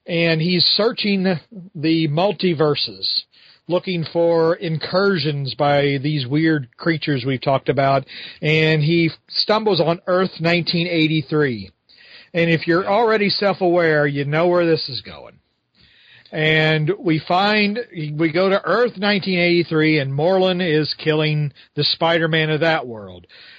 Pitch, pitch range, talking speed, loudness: 165 Hz, 150-180 Hz, 130 wpm, -18 LUFS